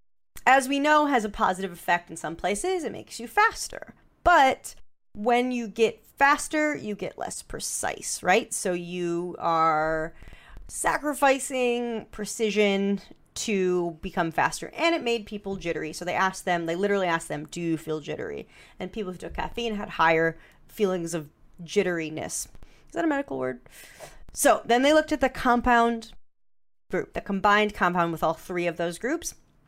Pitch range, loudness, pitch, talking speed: 170-240 Hz, -26 LUFS, 200 Hz, 165 wpm